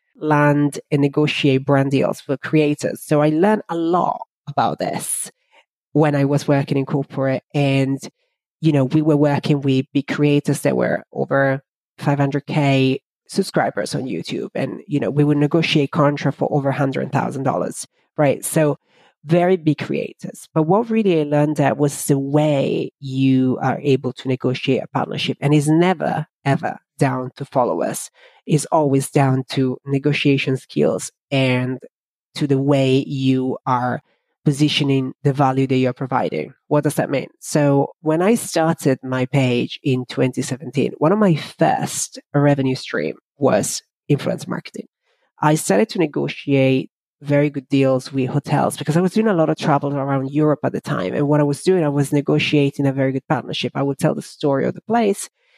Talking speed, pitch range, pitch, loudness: 170 wpm, 135-155 Hz, 145 Hz, -19 LUFS